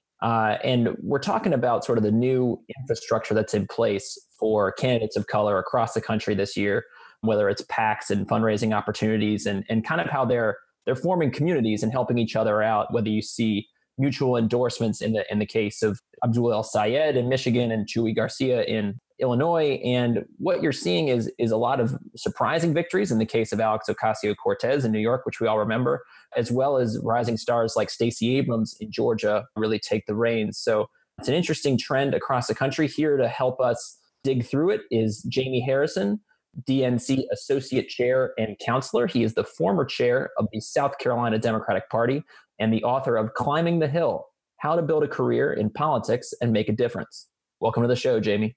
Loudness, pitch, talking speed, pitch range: -24 LUFS, 120 Hz, 195 wpm, 110-135 Hz